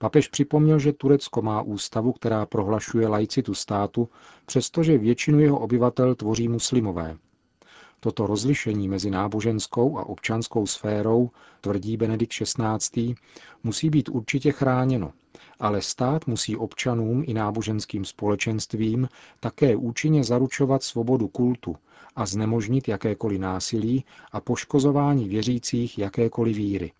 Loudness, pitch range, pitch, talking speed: -24 LUFS, 105-130 Hz, 115 Hz, 115 wpm